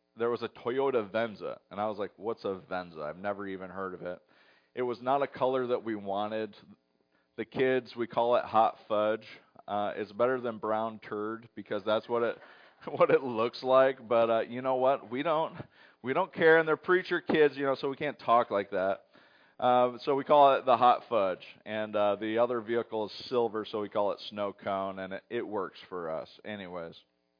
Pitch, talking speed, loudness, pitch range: 115 Hz, 210 wpm, -30 LUFS, 105-130 Hz